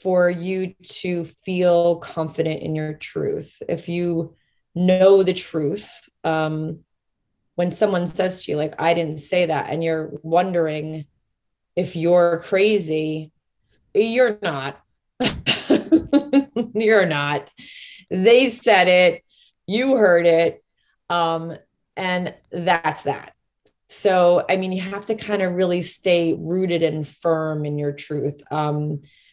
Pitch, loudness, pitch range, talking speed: 175 Hz, -20 LUFS, 155-185 Hz, 125 wpm